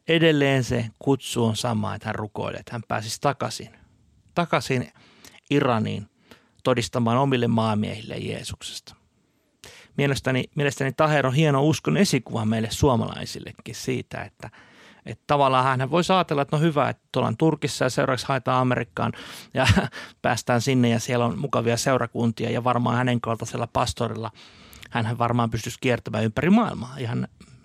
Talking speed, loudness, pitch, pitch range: 140 wpm, -24 LUFS, 125 Hz, 115-140 Hz